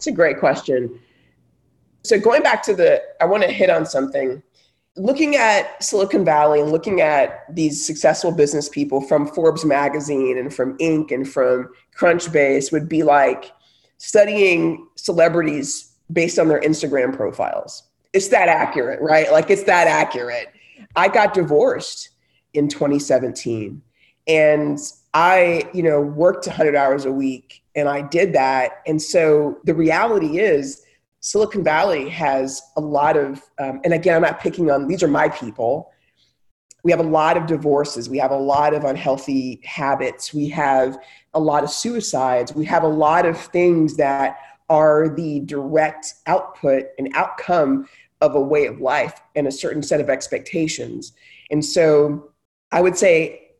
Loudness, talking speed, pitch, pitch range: -18 LUFS, 160 wpm, 150 Hz, 140-170 Hz